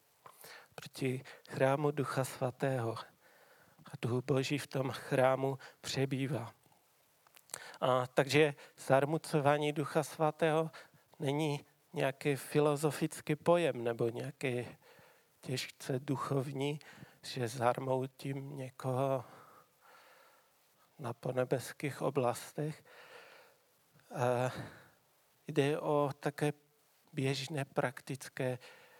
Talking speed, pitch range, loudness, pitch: 75 wpm, 130-150 Hz, -35 LUFS, 140 Hz